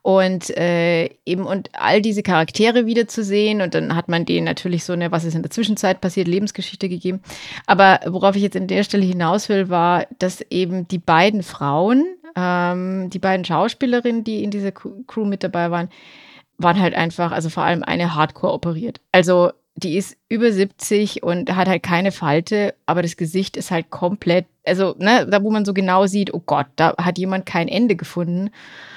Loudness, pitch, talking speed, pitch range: -19 LUFS, 185 Hz, 190 wpm, 170-205 Hz